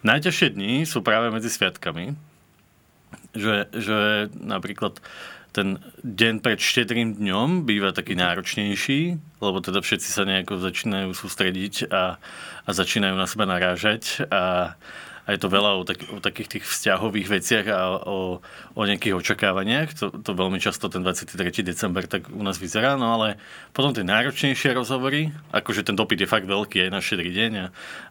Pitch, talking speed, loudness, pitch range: 105 Hz, 160 wpm, -23 LUFS, 95-115 Hz